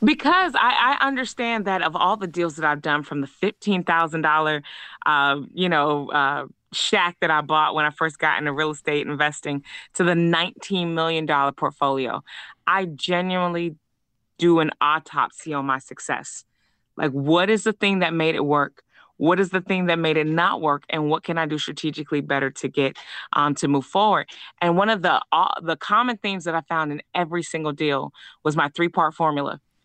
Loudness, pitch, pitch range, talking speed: -22 LUFS, 160 Hz, 145-180 Hz, 190 wpm